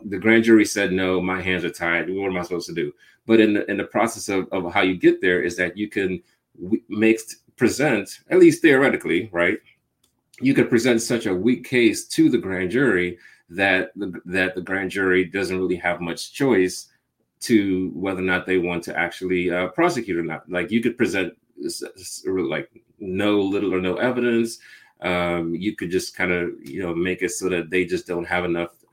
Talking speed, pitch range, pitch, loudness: 205 wpm, 90-110 Hz, 95 Hz, -21 LUFS